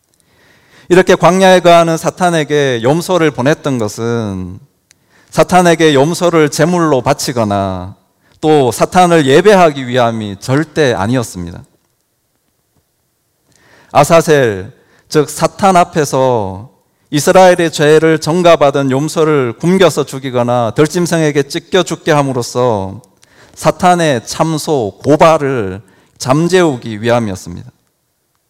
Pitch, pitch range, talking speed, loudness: 145 Hz, 120-165 Hz, 245 characters per minute, -11 LUFS